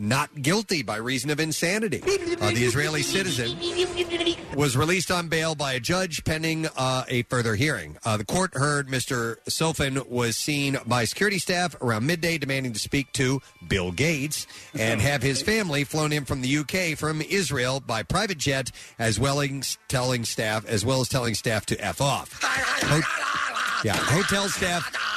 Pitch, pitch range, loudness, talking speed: 140 Hz, 125-165 Hz, -25 LUFS, 170 wpm